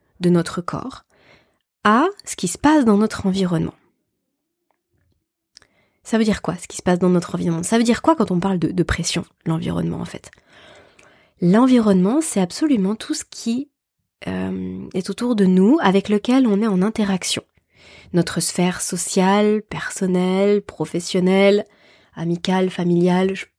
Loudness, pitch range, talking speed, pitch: -19 LUFS, 175-215 Hz, 155 wpm, 190 Hz